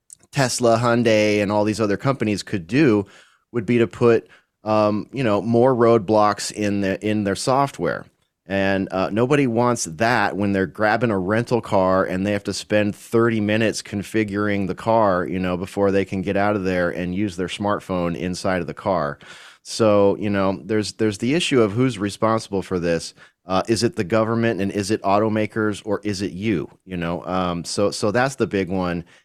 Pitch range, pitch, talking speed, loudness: 95-110 Hz, 105 Hz, 195 wpm, -21 LUFS